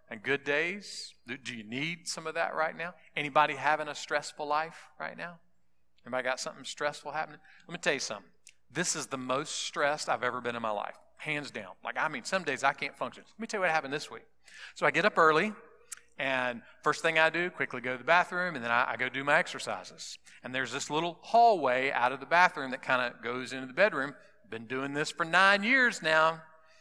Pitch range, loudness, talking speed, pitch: 130-165 Hz, -30 LUFS, 230 wpm, 150 Hz